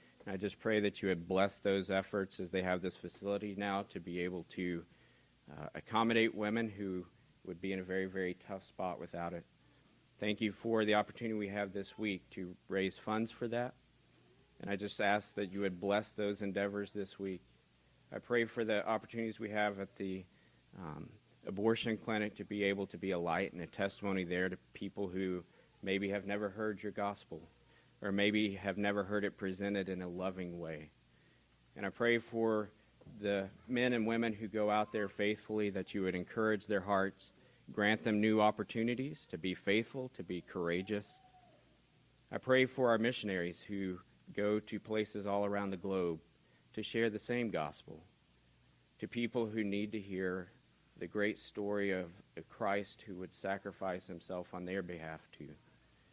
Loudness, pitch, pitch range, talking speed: -38 LUFS, 100 Hz, 95-110 Hz, 180 wpm